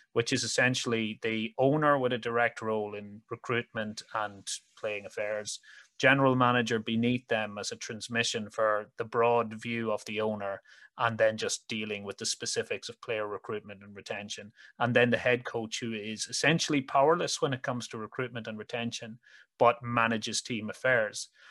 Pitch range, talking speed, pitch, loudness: 110-120 Hz, 165 wpm, 115 Hz, -30 LUFS